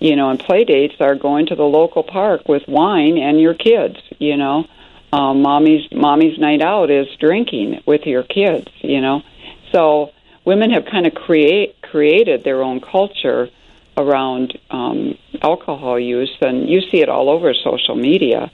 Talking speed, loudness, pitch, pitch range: 170 wpm, -15 LUFS, 150 Hz, 140-195 Hz